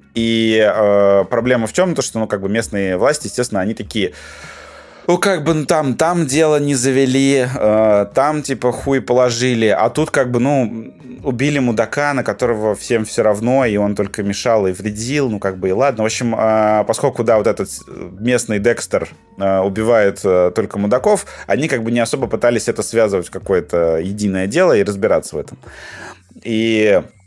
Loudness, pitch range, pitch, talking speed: -16 LUFS, 105-135 Hz, 115 Hz, 180 wpm